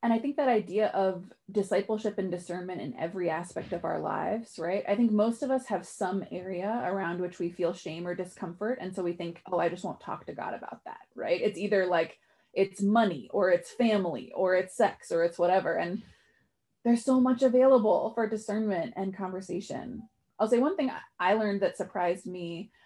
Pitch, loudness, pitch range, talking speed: 195 Hz, -30 LUFS, 180-220 Hz, 200 wpm